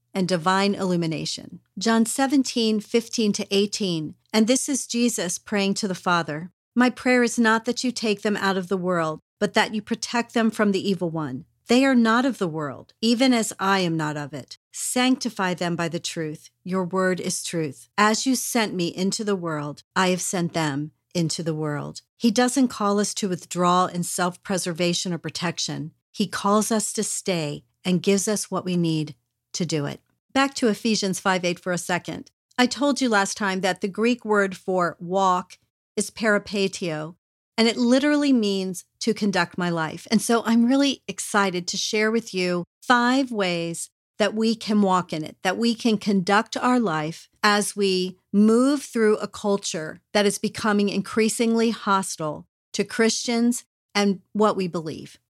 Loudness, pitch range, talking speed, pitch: -23 LUFS, 175-225 Hz, 180 wpm, 200 Hz